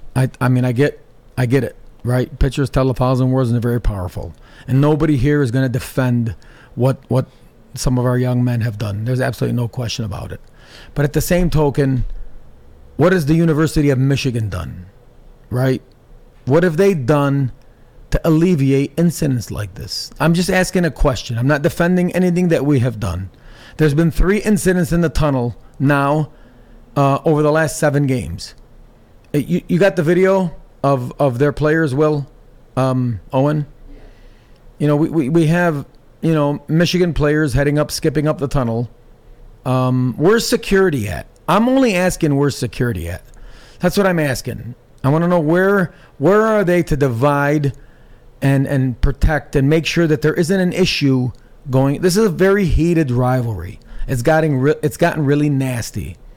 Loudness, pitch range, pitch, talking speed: -17 LUFS, 125-160 Hz, 140 Hz, 175 wpm